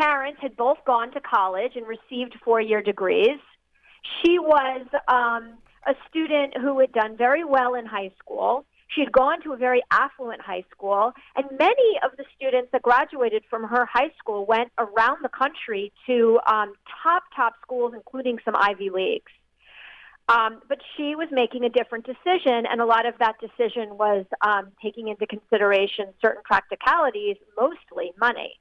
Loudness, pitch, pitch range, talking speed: -23 LUFS, 245 Hz, 225-280 Hz, 170 wpm